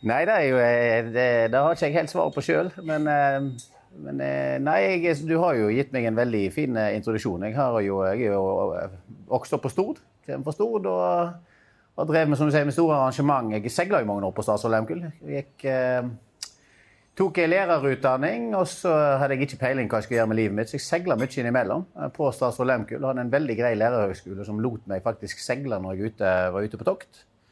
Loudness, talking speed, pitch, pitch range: -24 LUFS, 205 wpm, 125 Hz, 110-150 Hz